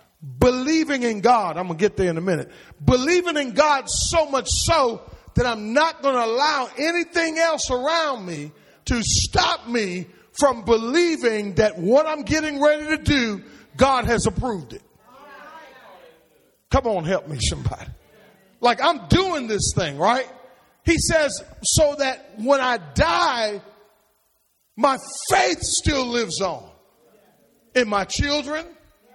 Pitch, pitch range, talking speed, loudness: 250 Hz, 215-305 Hz, 140 wpm, -21 LUFS